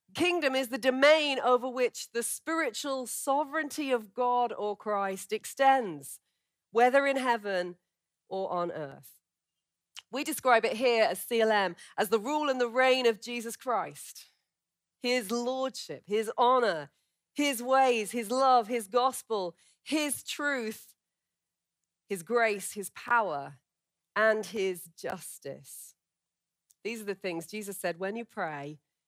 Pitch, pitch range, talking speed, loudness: 235 Hz, 200-260 Hz, 130 wpm, -29 LUFS